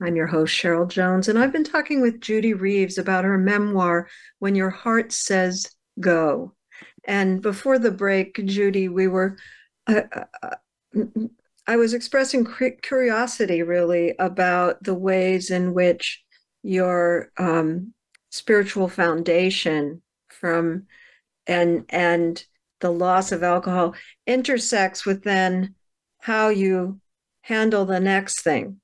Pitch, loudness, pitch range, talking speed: 190 Hz, -21 LUFS, 180-220 Hz, 120 wpm